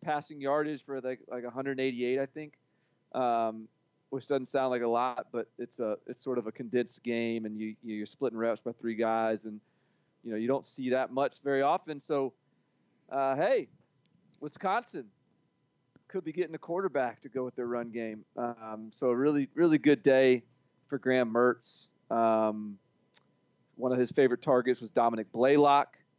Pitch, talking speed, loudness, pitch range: 125 Hz, 175 wpm, -31 LUFS, 115-140 Hz